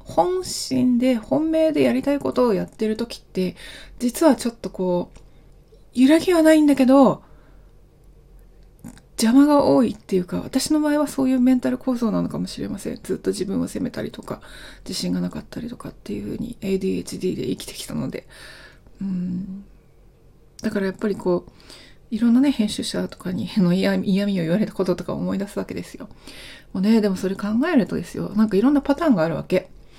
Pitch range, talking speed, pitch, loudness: 190-260 Hz, 370 characters per minute, 220 Hz, -21 LUFS